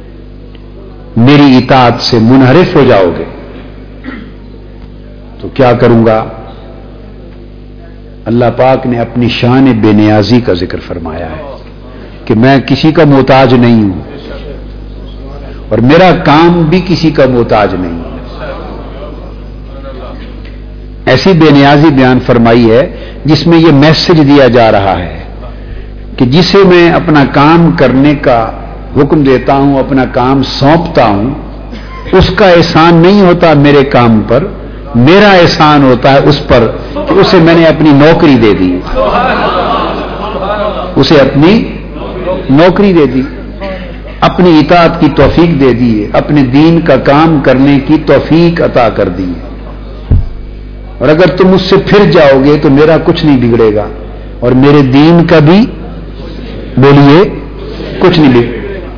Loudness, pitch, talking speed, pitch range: -6 LUFS, 130 Hz, 135 wpm, 115-155 Hz